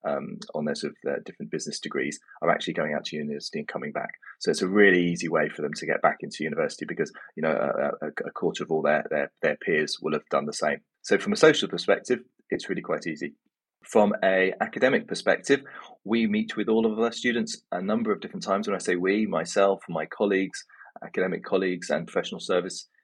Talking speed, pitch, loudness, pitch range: 225 wpm, 100 Hz, -26 LUFS, 90-115 Hz